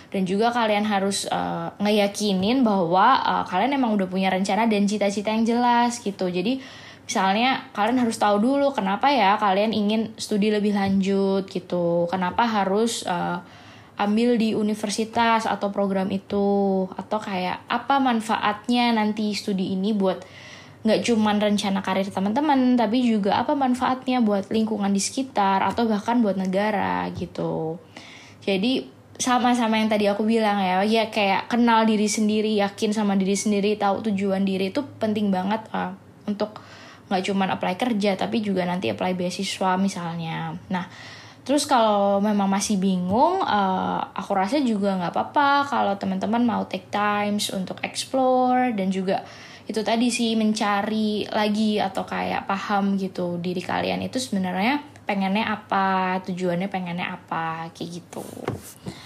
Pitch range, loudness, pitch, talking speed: 190-225 Hz, -23 LUFS, 205 Hz, 145 wpm